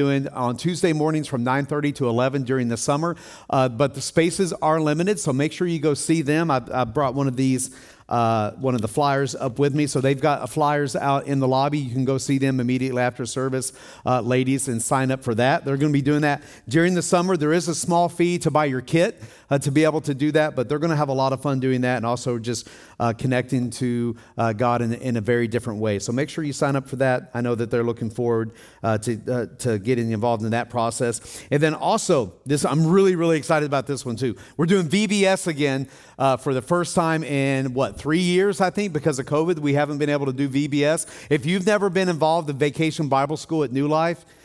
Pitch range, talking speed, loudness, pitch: 125-155 Hz, 250 wpm, -22 LUFS, 140 Hz